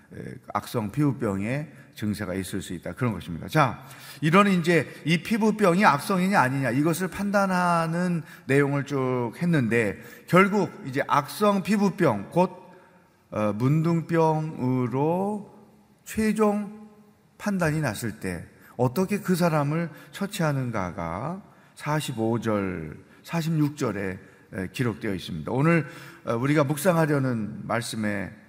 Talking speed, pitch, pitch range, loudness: 235 characters per minute, 150 Hz, 115-180 Hz, -25 LUFS